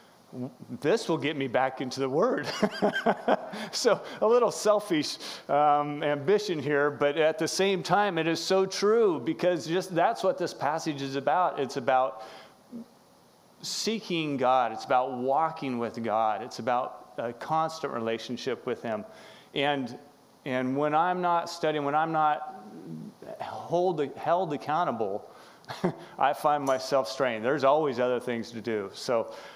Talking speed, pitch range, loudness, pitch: 160 wpm, 130-175 Hz, -28 LUFS, 150 Hz